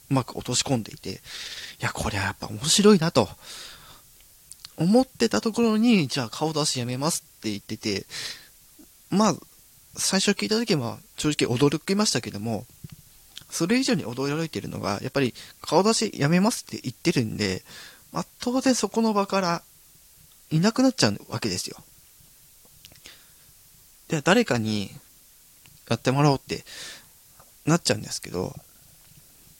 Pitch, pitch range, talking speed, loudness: 155 Hz, 125-205 Hz, 290 characters per minute, -25 LUFS